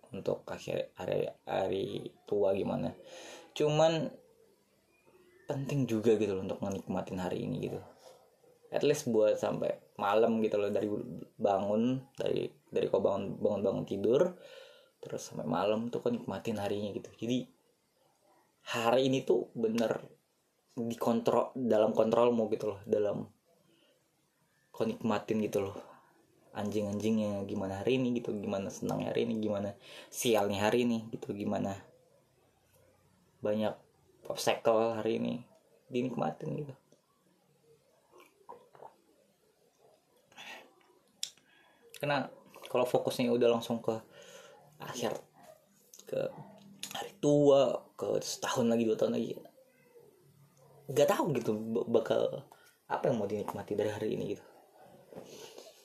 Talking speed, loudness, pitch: 115 wpm, -33 LUFS, 130 Hz